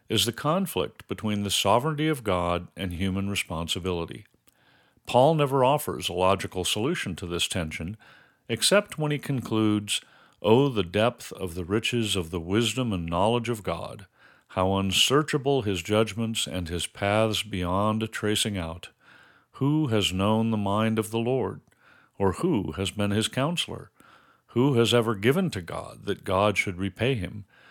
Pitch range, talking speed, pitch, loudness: 95-120 Hz, 160 wpm, 105 Hz, -26 LUFS